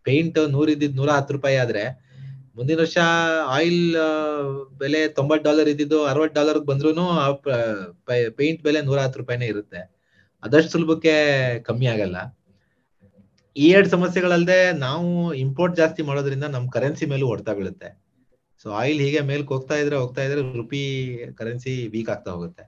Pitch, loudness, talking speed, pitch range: 140 Hz, -21 LUFS, 140 wpm, 125-155 Hz